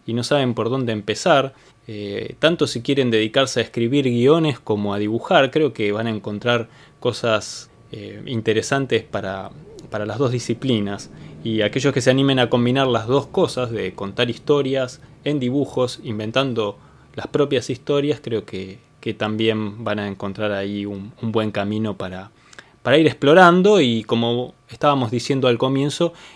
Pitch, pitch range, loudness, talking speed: 120 Hz, 110-135 Hz, -20 LUFS, 160 wpm